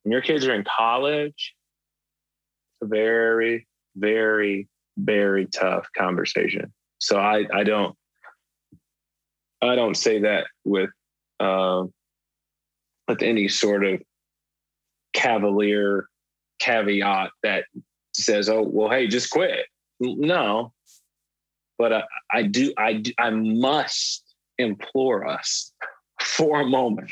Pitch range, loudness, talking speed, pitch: 100-120 Hz, -23 LUFS, 110 wpm, 110 Hz